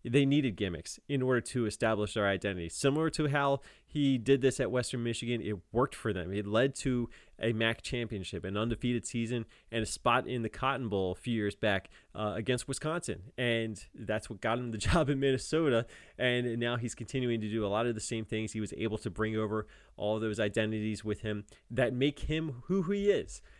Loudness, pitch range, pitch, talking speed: -33 LUFS, 110-130 Hz, 115 Hz, 215 wpm